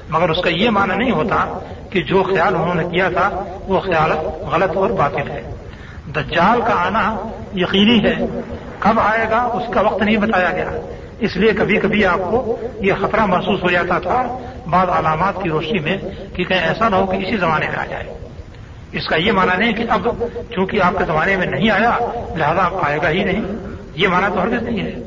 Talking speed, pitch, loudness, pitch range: 205 wpm, 200 Hz, -17 LUFS, 180-225 Hz